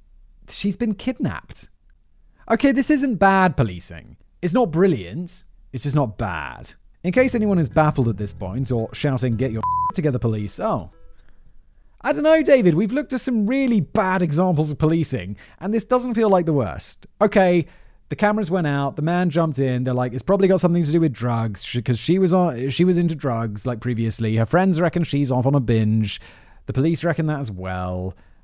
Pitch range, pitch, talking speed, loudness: 115-190 Hz, 155 Hz, 195 wpm, -20 LUFS